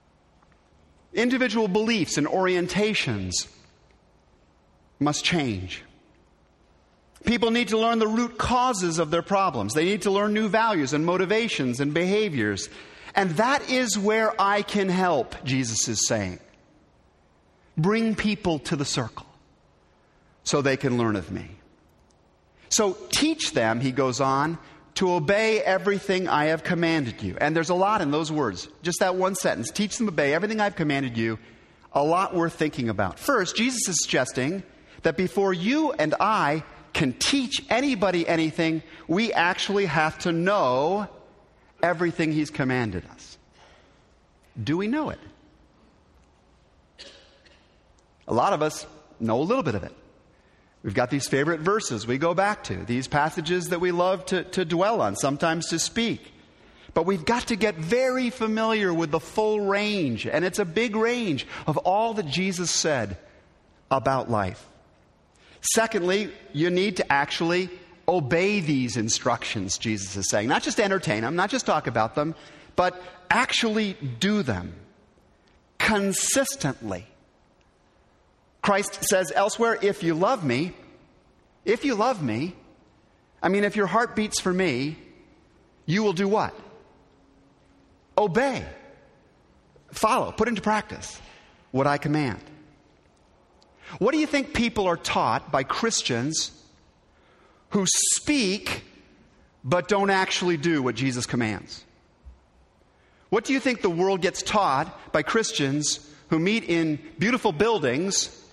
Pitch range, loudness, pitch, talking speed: 130-205 Hz, -24 LUFS, 170 Hz, 140 wpm